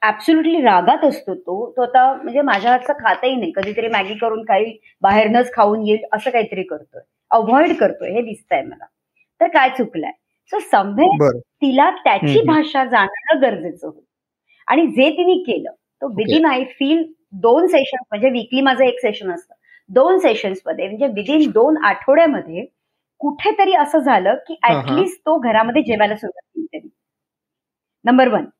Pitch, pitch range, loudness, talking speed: 265 Hz, 220-320 Hz, -16 LUFS, 135 wpm